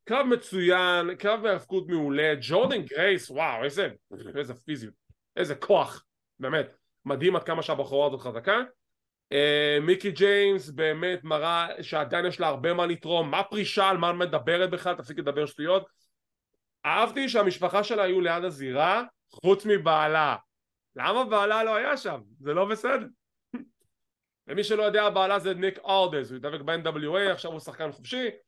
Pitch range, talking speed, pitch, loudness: 155-200 Hz, 150 wpm, 180 Hz, -26 LUFS